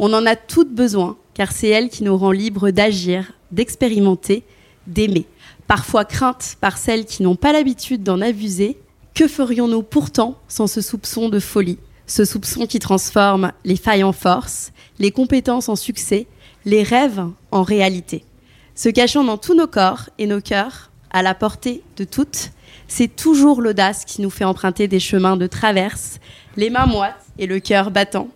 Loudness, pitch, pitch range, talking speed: -17 LUFS, 205 Hz, 190-235 Hz, 170 wpm